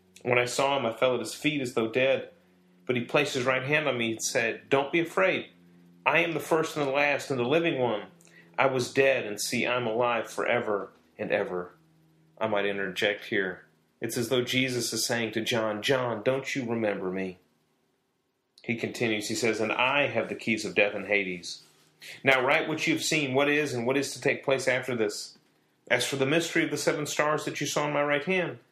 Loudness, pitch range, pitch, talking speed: -27 LUFS, 105-145 Hz, 125 Hz, 225 wpm